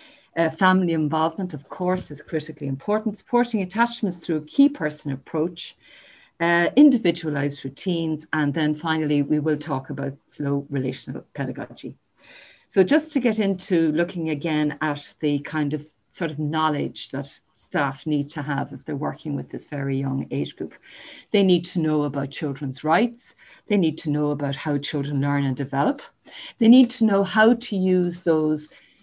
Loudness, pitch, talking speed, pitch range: -23 LUFS, 155 Hz, 165 wpm, 145-190 Hz